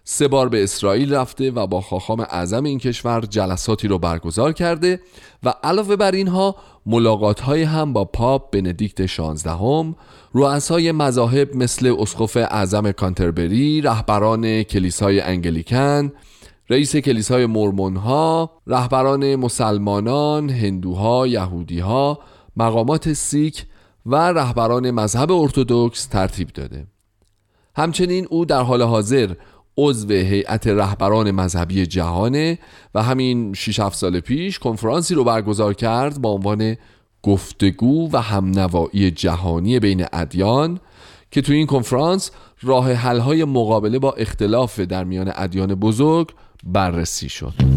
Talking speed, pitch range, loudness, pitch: 120 wpm, 100-140 Hz, -19 LUFS, 115 Hz